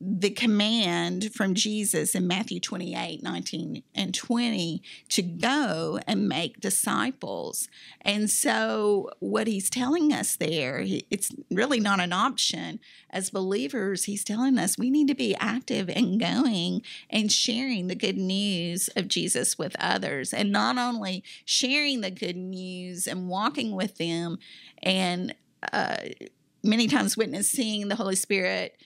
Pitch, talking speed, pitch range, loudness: 205 Hz, 140 wpm, 185-240 Hz, -26 LUFS